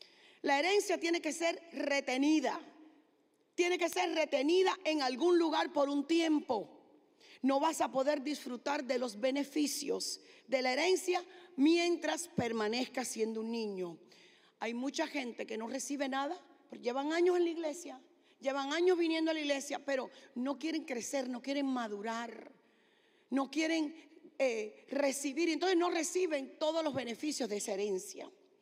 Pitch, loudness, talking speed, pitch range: 295 Hz, -34 LUFS, 150 wpm, 265-335 Hz